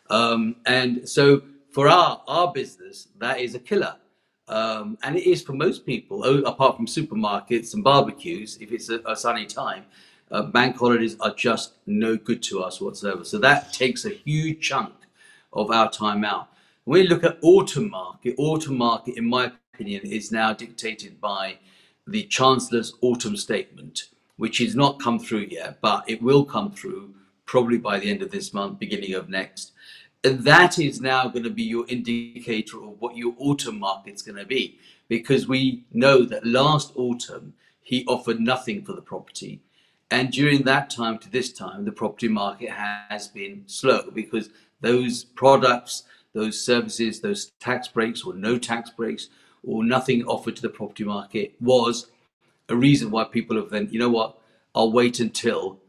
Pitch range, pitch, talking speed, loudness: 110-135 Hz, 120 Hz, 175 wpm, -23 LUFS